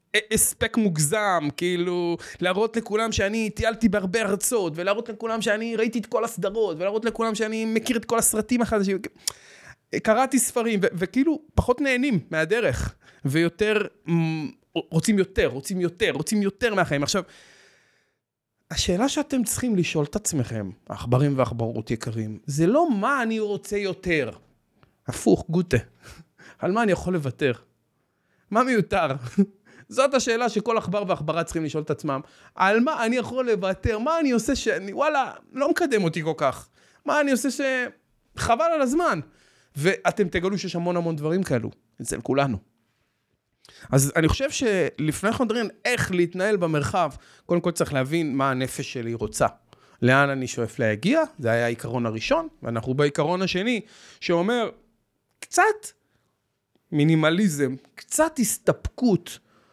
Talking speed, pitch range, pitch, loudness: 140 wpm, 150-225 Hz, 190 Hz, -24 LUFS